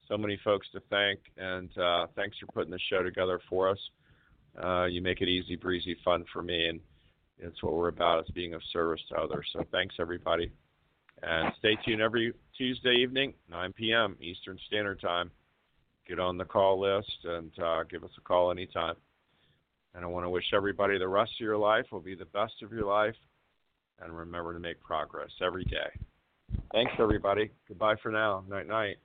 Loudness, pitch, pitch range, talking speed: -31 LUFS, 95 Hz, 85-105 Hz, 190 wpm